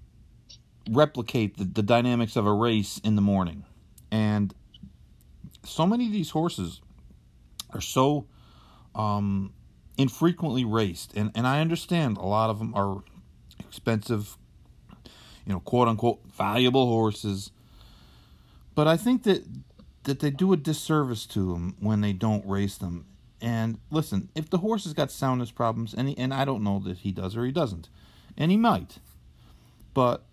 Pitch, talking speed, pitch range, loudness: 115 Hz, 155 wpm, 100-145 Hz, -27 LUFS